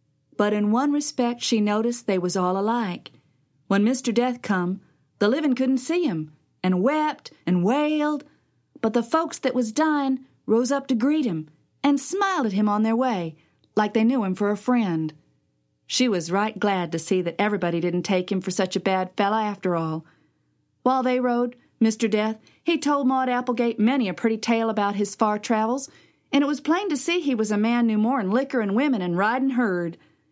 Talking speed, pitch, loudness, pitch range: 200 wpm, 225 Hz, -23 LUFS, 185-260 Hz